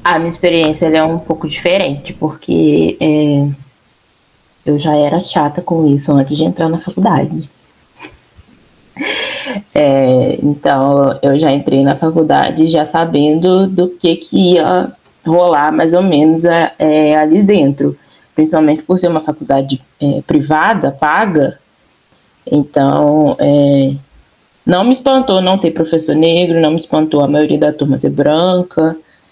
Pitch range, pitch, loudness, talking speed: 145-170 Hz, 155 Hz, -12 LUFS, 135 wpm